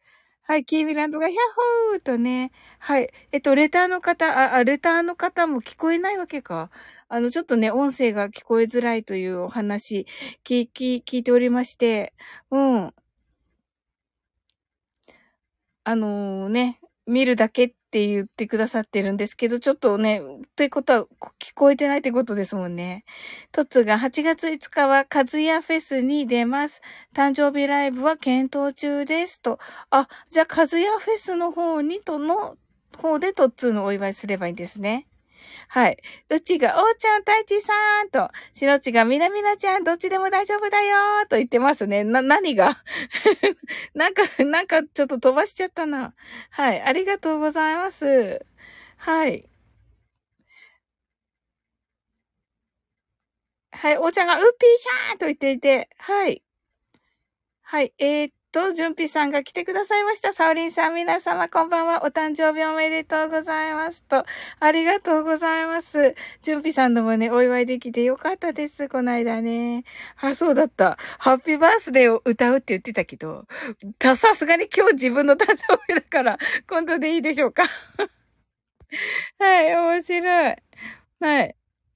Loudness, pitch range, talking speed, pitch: -21 LUFS, 245-335 Hz, 315 characters per minute, 290 Hz